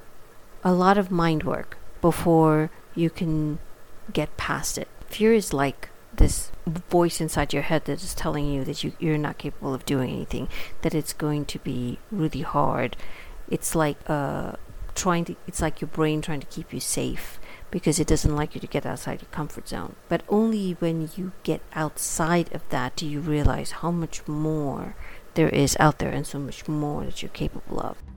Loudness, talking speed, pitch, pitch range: -26 LUFS, 190 wpm, 155 Hz, 145-170 Hz